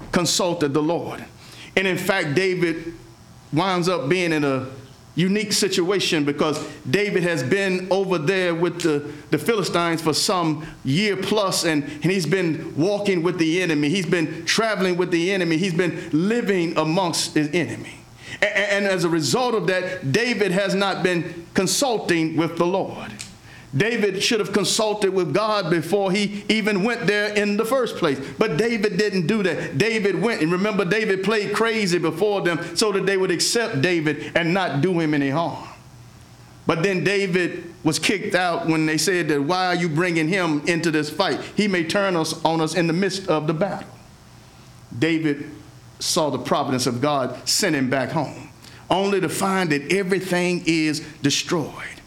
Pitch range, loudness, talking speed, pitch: 155-195 Hz, -21 LUFS, 175 wpm, 175 Hz